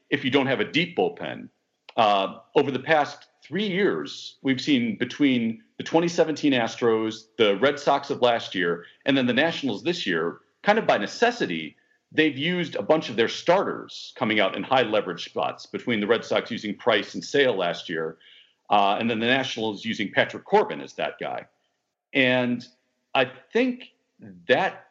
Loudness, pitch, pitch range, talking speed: -24 LUFS, 135 Hz, 115-180 Hz, 175 wpm